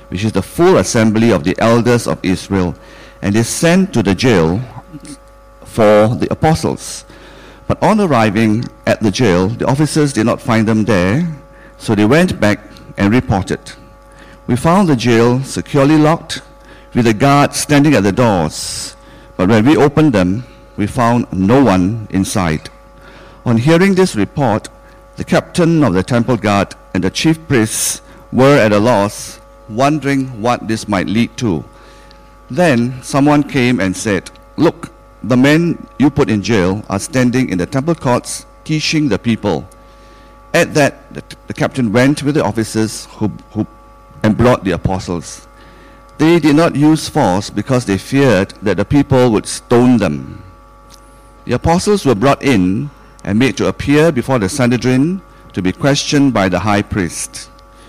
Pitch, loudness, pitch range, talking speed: 120 Hz, -13 LUFS, 100-140 Hz, 160 wpm